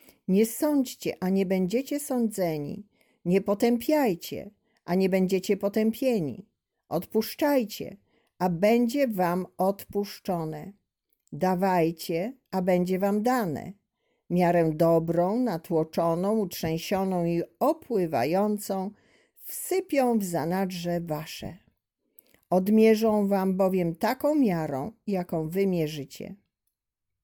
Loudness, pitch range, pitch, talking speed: -26 LUFS, 175-220 Hz, 195 Hz, 85 wpm